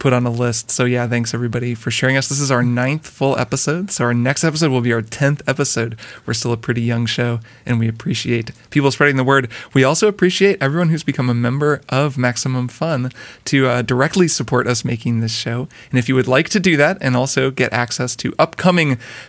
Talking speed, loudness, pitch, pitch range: 225 wpm, -17 LUFS, 130 Hz, 120-145 Hz